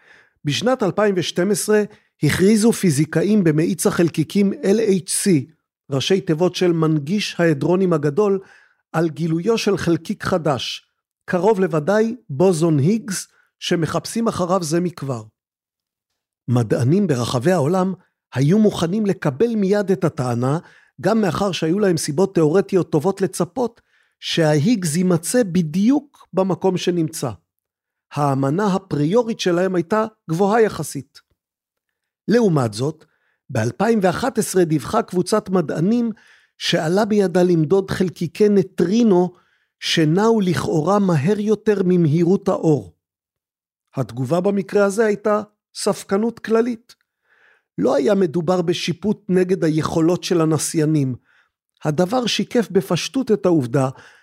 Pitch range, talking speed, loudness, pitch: 160-205 Hz, 100 wpm, -19 LUFS, 180 Hz